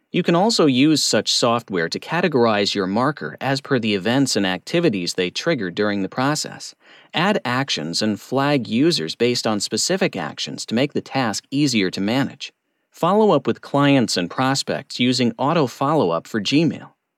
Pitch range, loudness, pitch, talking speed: 105-145 Hz, -20 LUFS, 125 Hz, 170 wpm